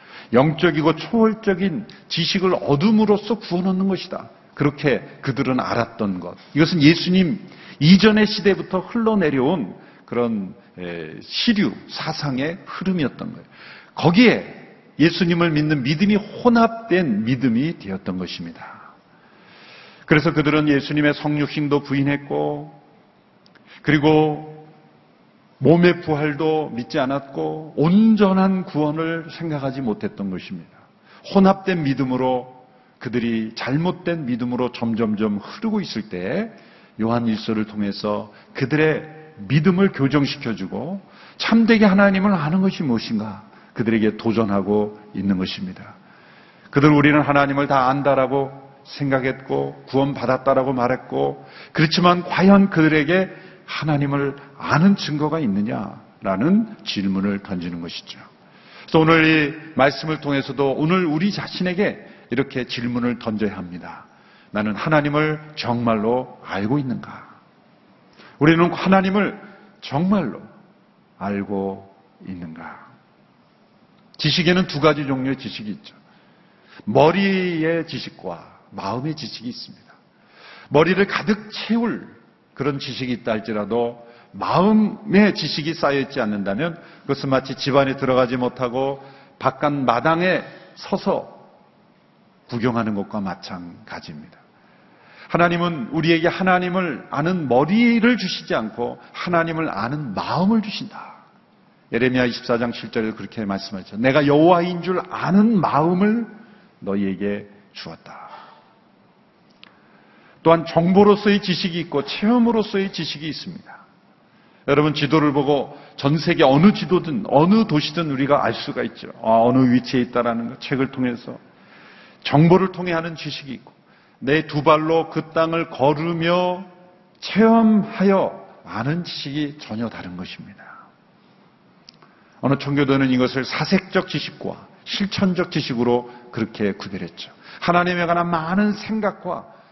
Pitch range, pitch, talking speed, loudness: 125-185 Hz, 150 Hz, 280 characters per minute, -20 LUFS